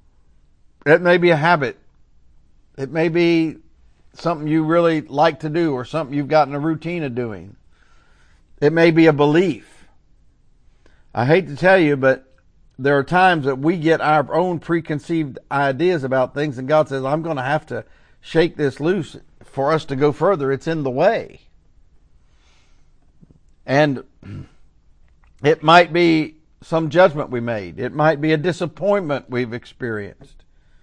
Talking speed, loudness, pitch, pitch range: 155 wpm, -18 LUFS, 150 Hz, 125-165 Hz